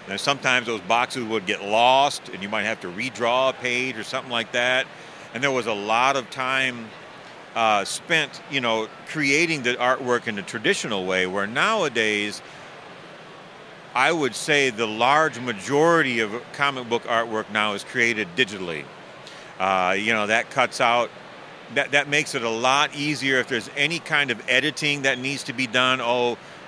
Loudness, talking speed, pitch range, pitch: -22 LUFS, 175 wpm, 115-140 Hz, 125 Hz